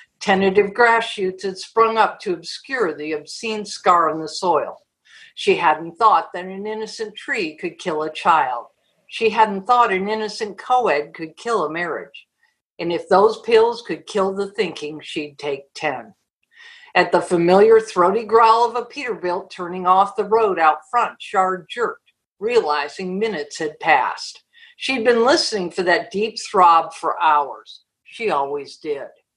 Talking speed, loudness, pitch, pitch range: 160 wpm, -19 LUFS, 200 Hz, 175-235 Hz